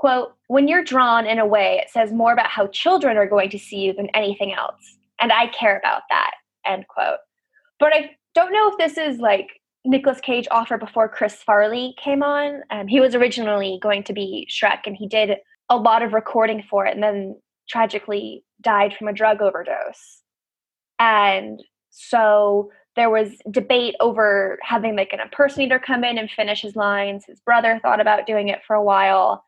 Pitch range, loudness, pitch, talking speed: 205-260 Hz, -19 LUFS, 225 Hz, 190 wpm